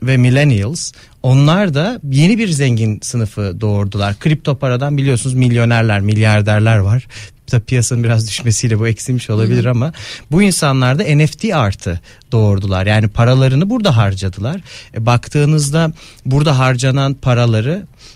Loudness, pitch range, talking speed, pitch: -14 LUFS, 110-140 Hz, 125 wpm, 125 Hz